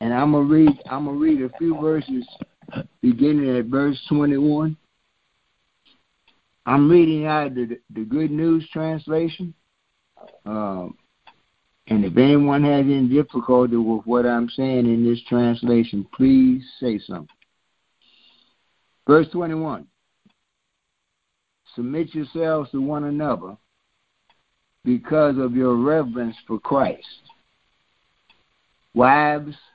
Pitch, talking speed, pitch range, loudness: 140 Hz, 110 wpm, 120-155 Hz, -20 LUFS